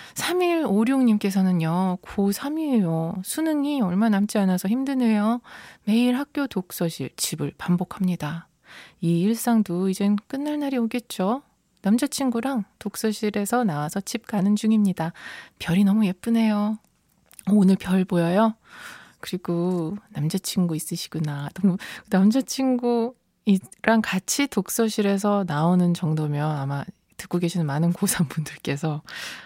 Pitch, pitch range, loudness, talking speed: 200 Hz, 175-230 Hz, -24 LUFS, 265 characters per minute